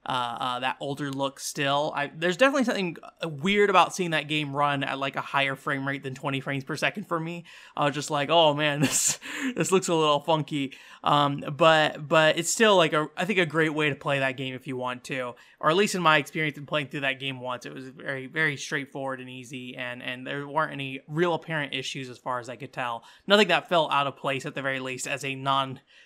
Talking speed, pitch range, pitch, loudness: 245 wpm, 135-160 Hz, 145 Hz, -26 LUFS